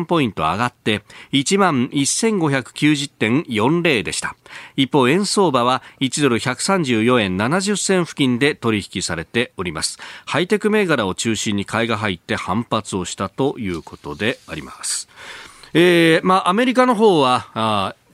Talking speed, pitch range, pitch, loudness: 250 characters per minute, 110-175 Hz, 135 Hz, -18 LUFS